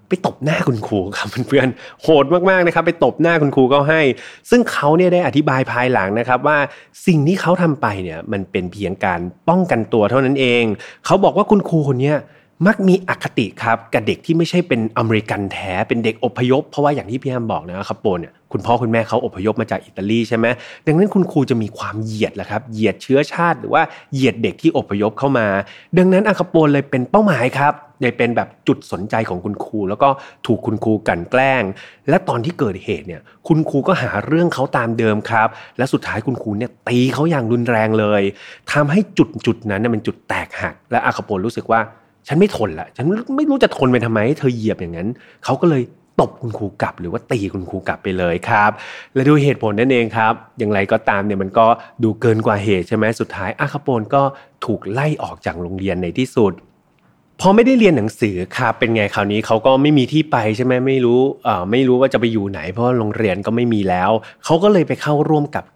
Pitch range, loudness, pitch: 110-150 Hz, -17 LUFS, 125 Hz